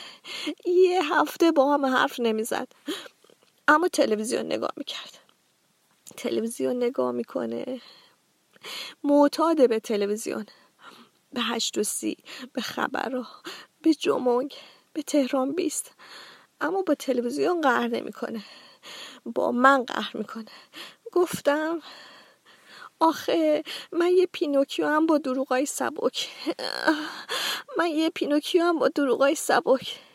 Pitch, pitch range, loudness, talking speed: 285 Hz, 245-320 Hz, -25 LUFS, 105 wpm